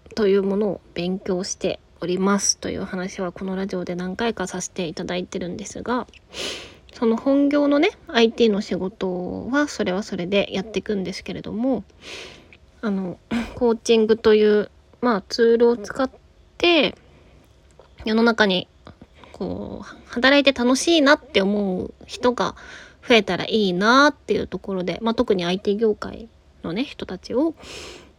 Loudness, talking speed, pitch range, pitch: -21 LUFS, 295 characters per minute, 190-240 Hz, 215 Hz